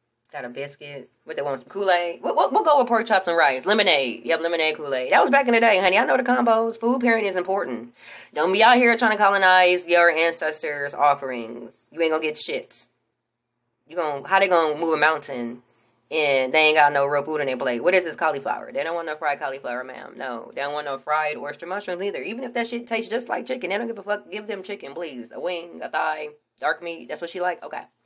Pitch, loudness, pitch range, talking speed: 165 Hz, -21 LUFS, 140-200 Hz, 250 wpm